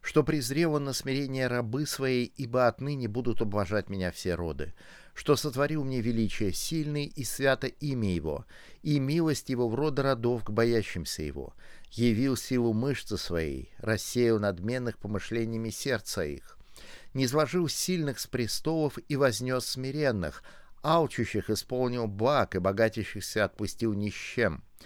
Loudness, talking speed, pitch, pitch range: -30 LUFS, 140 wpm, 120 Hz, 105-140 Hz